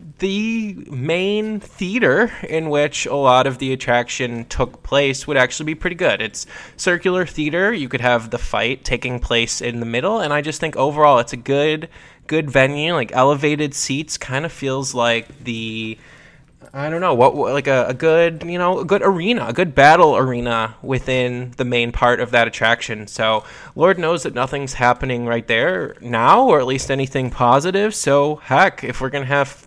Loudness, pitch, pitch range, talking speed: -18 LUFS, 140 Hz, 125-160 Hz, 185 wpm